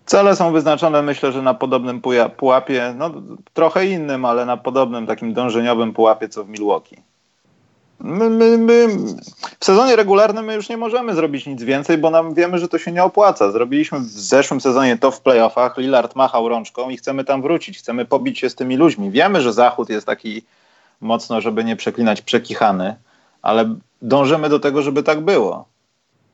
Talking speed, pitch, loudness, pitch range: 180 wpm, 135 Hz, -16 LUFS, 120-170 Hz